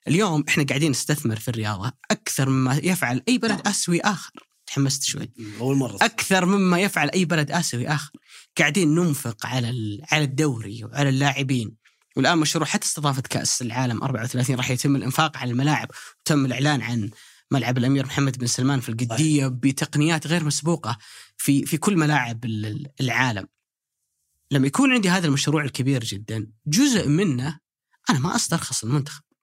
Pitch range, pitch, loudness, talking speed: 125-155 Hz, 140 Hz, -22 LUFS, 150 wpm